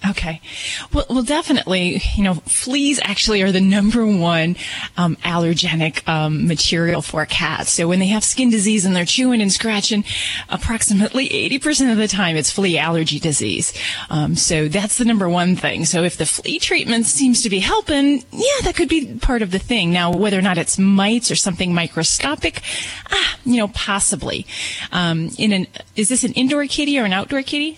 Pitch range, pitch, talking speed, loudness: 170-245 Hz, 200 Hz, 190 wpm, -17 LUFS